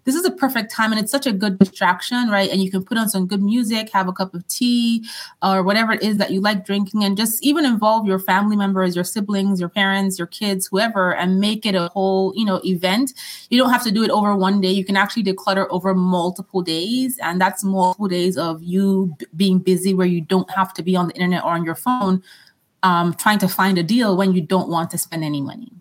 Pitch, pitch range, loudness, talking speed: 195 Hz, 185-215 Hz, -19 LUFS, 250 wpm